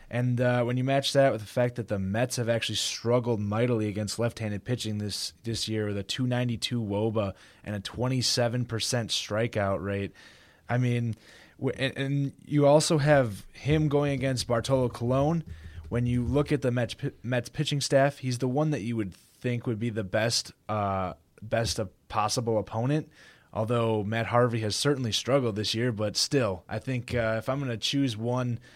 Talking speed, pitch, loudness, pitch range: 185 wpm, 120 Hz, -28 LUFS, 110-130 Hz